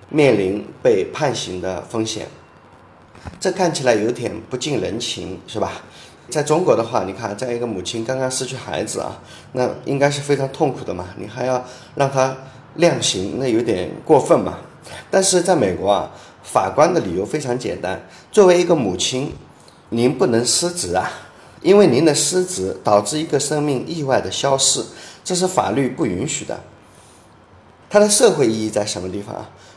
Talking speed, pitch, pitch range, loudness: 255 characters per minute, 130 Hz, 110-155 Hz, -18 LUFS